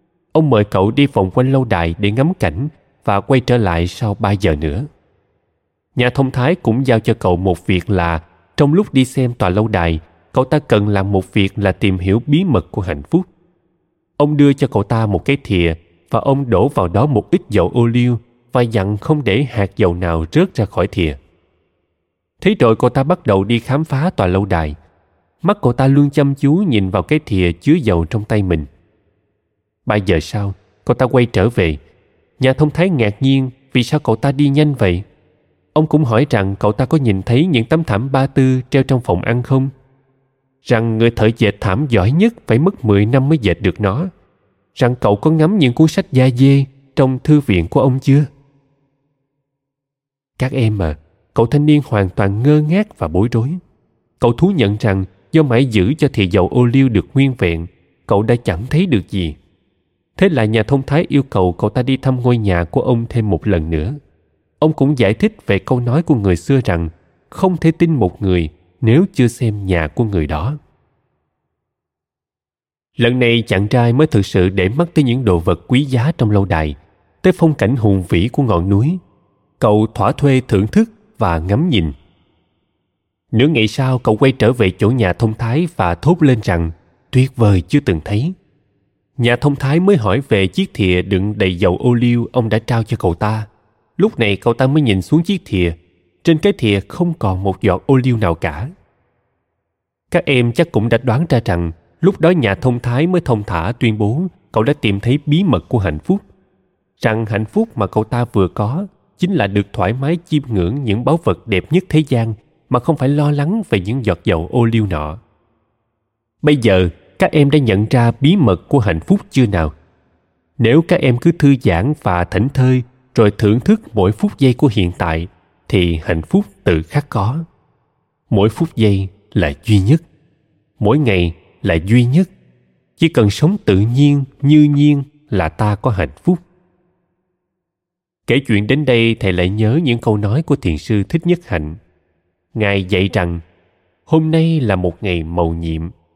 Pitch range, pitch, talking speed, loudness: 95-140 Hz, 115 Hz, 200 wpm, -15 LUFS